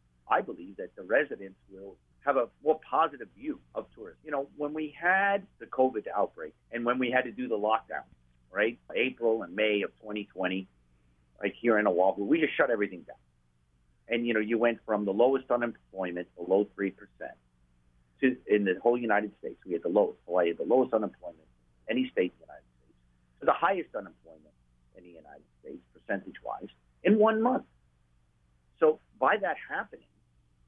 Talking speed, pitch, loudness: 185 wpm, 95 Hz, -29 LUFS